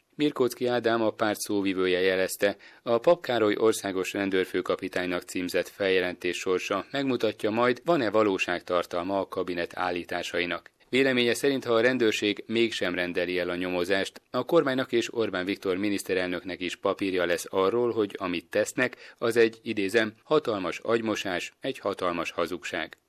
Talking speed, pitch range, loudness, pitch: 135 wpm, 90-120 Hz, -27 LUFS, 105 Hz